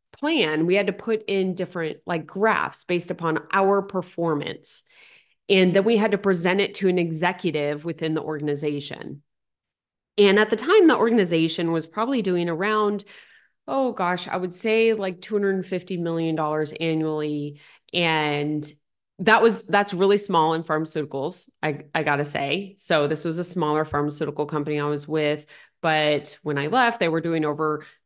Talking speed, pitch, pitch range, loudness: 165 wpm, 170 Hz, 155-195 Hz, -23 LUFS